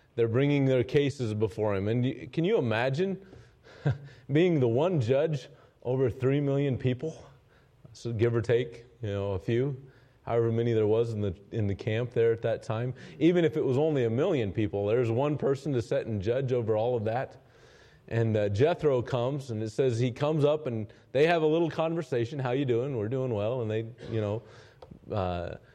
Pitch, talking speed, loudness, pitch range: 125 Hz, 200 wpm, -29 LUFS, 115-140 Hz